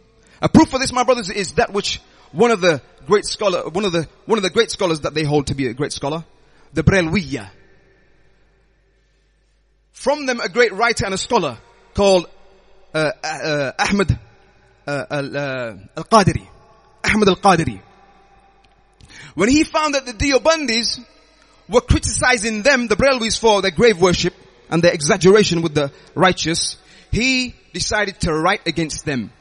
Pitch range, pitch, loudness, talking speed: 155-230 Hz, 195 Hz, -18 LUFS, 155 wpm